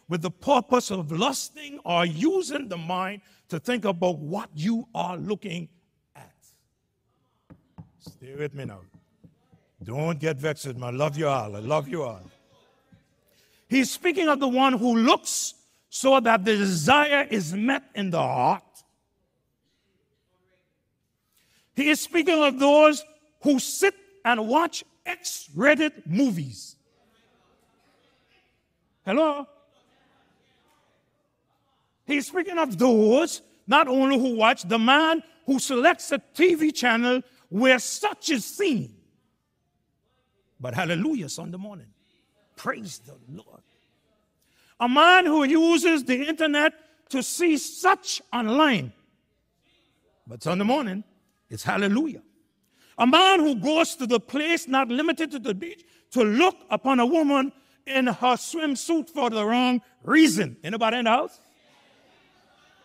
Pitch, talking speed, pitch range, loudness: 255 Hz, 125 wpm, 200-305 Hz, -23 LUFS